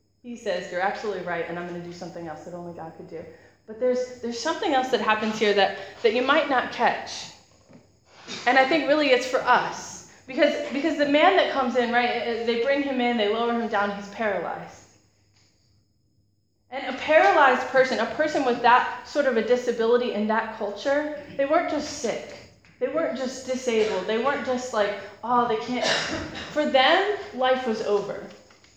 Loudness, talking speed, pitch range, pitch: -23 LUFS, 190 wpm, 205-265 Hz, 240 Hz